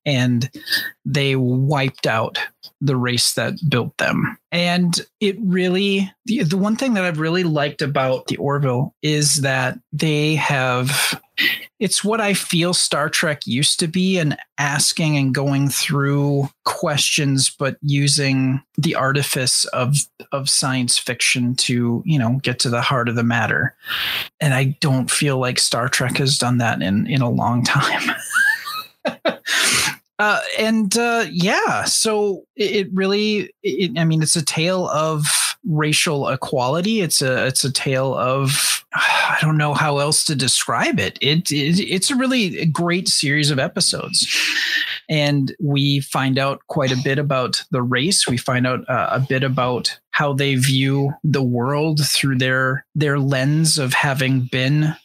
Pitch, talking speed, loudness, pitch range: 145 Hz, 150 wpm, -18 LUFS, 130-170 Hz